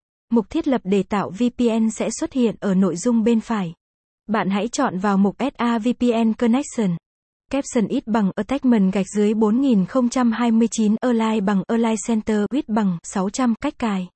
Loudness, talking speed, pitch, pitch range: -20 LUFS, 160 wpm, 225 Hz, 205-245 Hz